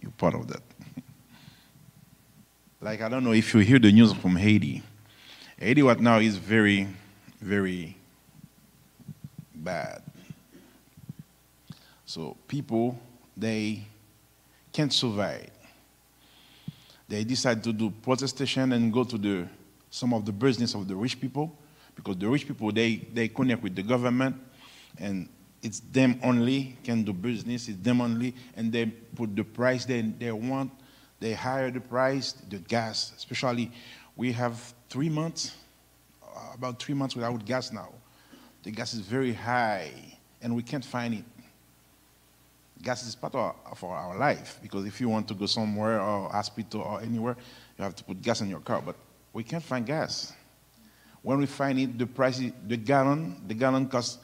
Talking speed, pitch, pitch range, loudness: 155 wpm, 115 Hz, 105-130 Hz, -28 LUFS